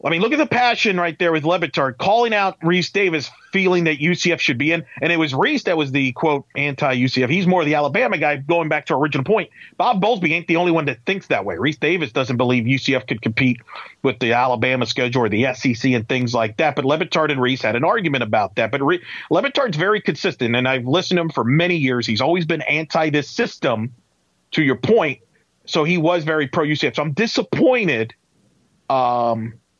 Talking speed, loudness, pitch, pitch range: 220 wpm, -18 LUFS, 155 Hz, 130-175 Hz